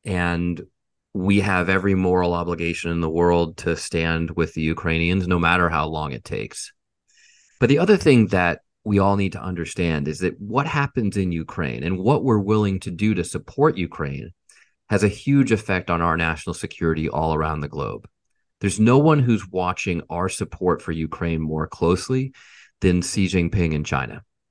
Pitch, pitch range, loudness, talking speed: 90 Hz, 85-100 Hz, -21 LUFS, 180 wpm